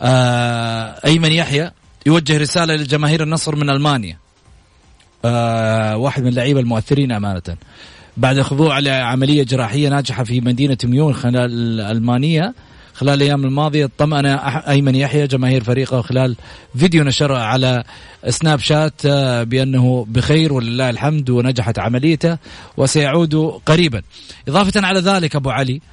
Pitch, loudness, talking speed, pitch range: 135 Hz, -16 LUFS, 125 wpm, 120-150 Hz